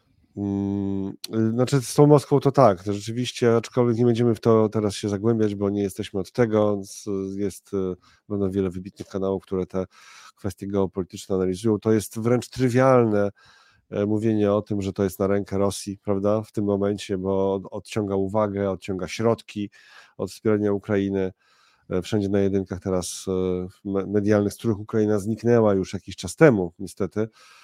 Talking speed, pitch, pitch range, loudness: 150 wpm, 100 Hz, 95-110 Hz, -24 LUFS